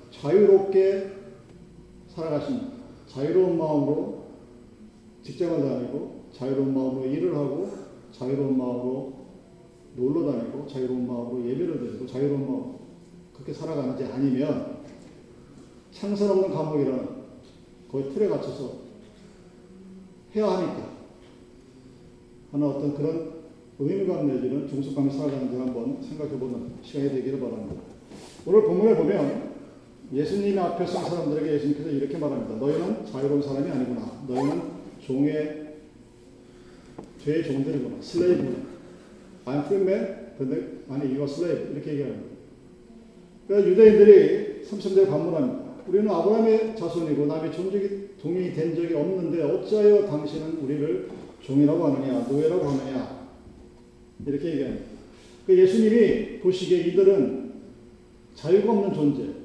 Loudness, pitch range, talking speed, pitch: -24 LUFS, 135-195 Hz, 340 characters per minute, 150 Hz